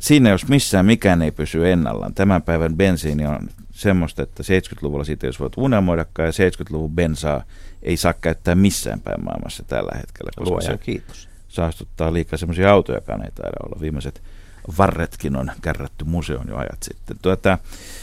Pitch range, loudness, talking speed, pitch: 80-95 Hz, -20 LUFS, 160 wpm, 85 Hz